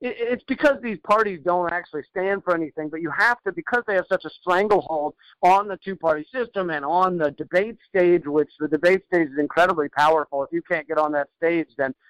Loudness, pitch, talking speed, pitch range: -22 LUFS, 175 Hz, 220 wpm, 155-195 Hz